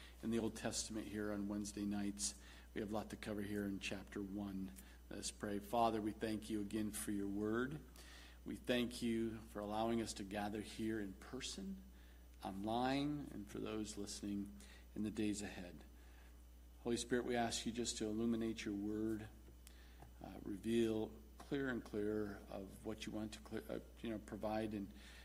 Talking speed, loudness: 180 wpm, -44 LUFS